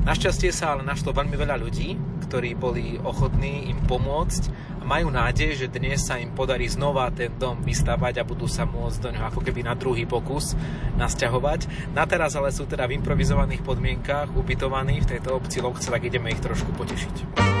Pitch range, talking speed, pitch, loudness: 125-150 Hz, 185 wpm, 140 Hz, -25 LUFS